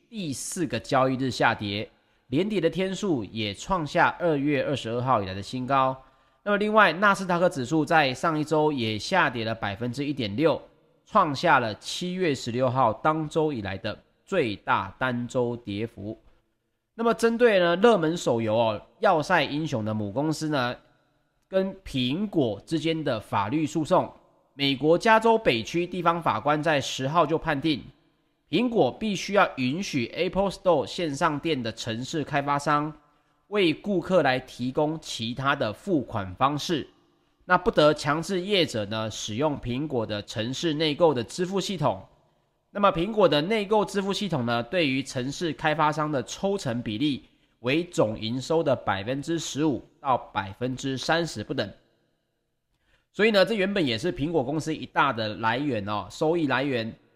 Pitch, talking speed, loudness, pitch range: 150 Hz, 250 characters per minute, -25 LUFS, 120-170 Hz